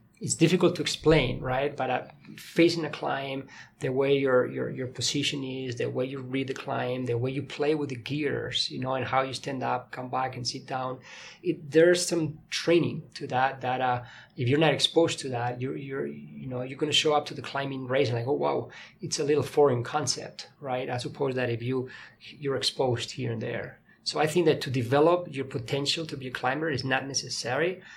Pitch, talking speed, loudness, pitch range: 135 Hz, 220 wpm, -28 LUFS, 125-150 Hz